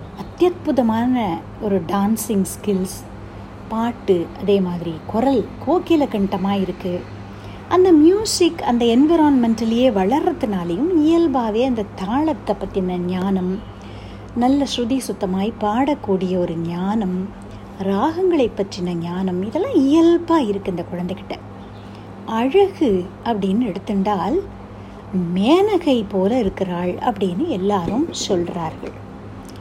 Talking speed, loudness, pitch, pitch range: 90 wpm, -19 LUFS, 200 Hz, 180-265 Hz